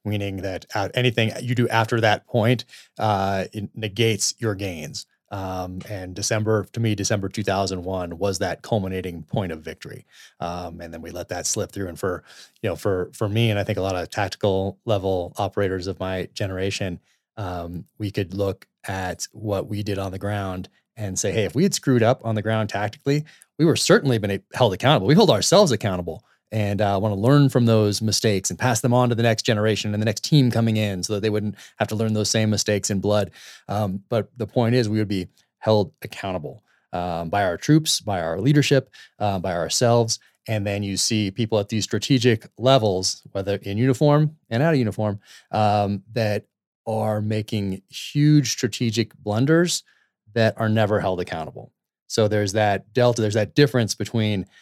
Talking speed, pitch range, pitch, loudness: 195 wpm, 95-115 Hz, 105 Hz, -22 LUFS